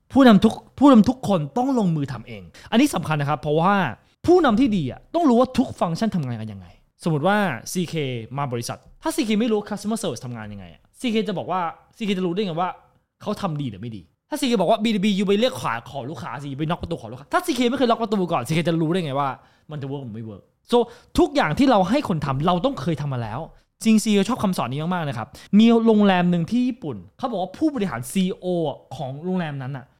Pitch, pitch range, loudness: 180 Hz, 140-225 Hz, -22 LUFS